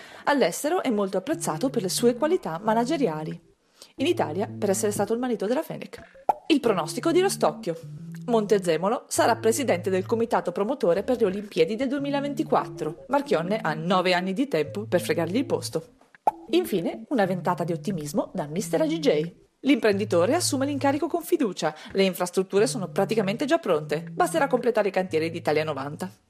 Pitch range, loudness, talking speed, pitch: 170-275 Hz, -25 LUFS, 155 wpm, 210 Hz